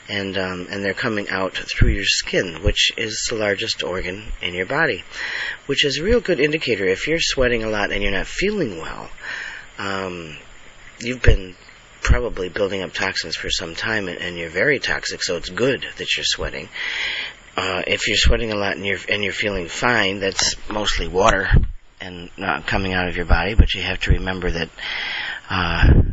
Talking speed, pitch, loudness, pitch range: 215 wpm, 95 Hz, -21 LUFS, 90-110 Hz